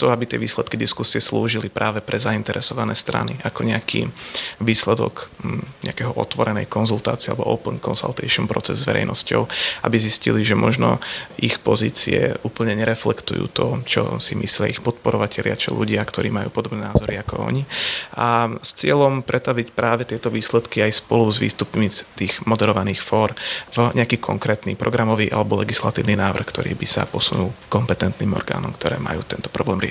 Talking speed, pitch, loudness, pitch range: 150 wpm, 110 Hz, -20 LUFS, 105-120 Hz